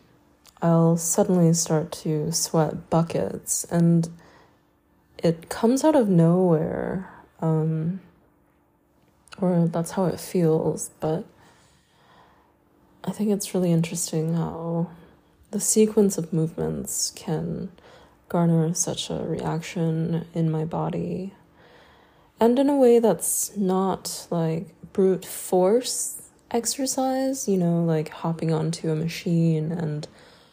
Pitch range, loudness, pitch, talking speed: 160-190 Hz, -24 LUFS, 170 Hz, 110 wpm